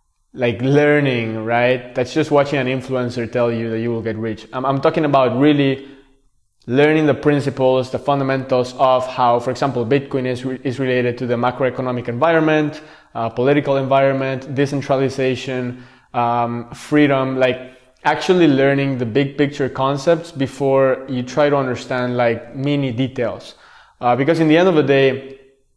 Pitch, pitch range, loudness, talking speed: 135 Hz, 125-140 Hz, -17 LUFS, 155 wpm